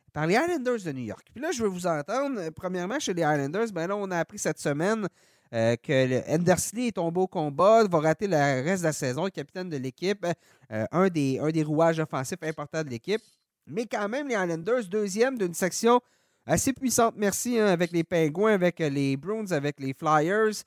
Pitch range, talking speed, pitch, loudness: 150-210 Hz, 210 wpm, 175 Hz, -27 LUFS